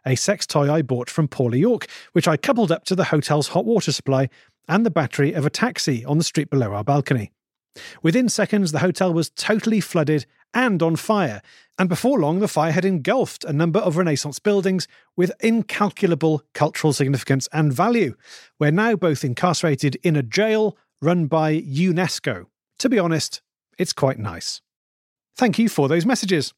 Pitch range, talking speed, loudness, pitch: 145-200 Hz, 180 wpm, -21 LUFS, 165 Hz